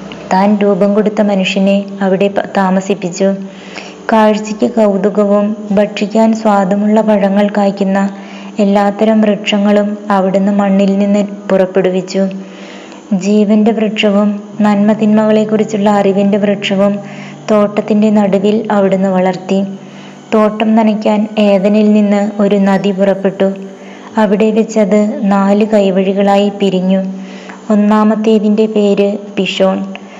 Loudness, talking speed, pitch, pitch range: -11 LUFS, 85 wpm, 205 Hz, 195-215 Hz